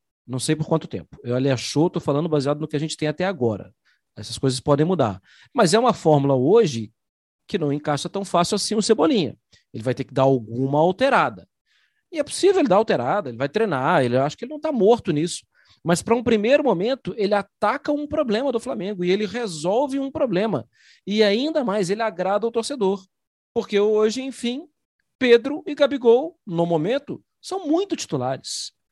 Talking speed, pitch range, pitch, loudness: 195 wpm, 150-240 Hz, 195 Hz, -21 LUFS